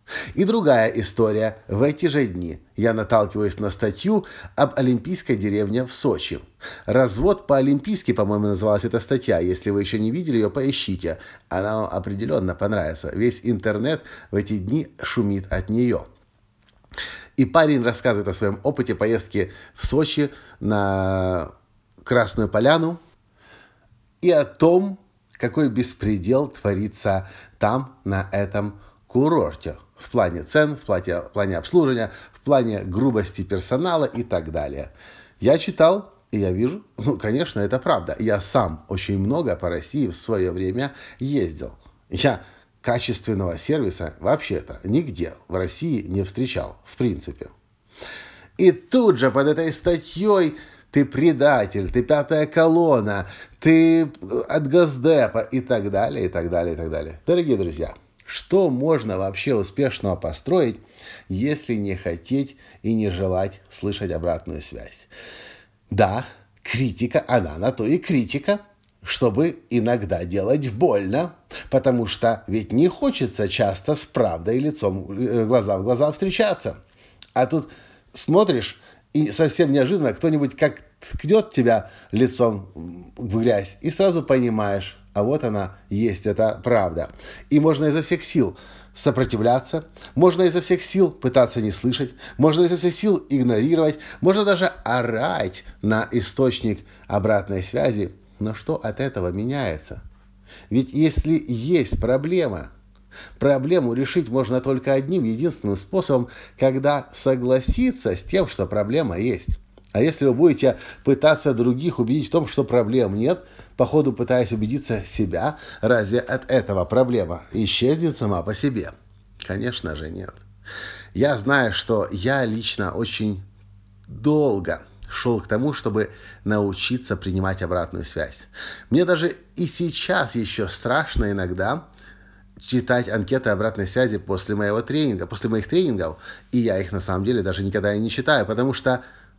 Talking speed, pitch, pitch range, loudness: 135 wpm, 120 Hz, 100-140 Hz, -22 LUFS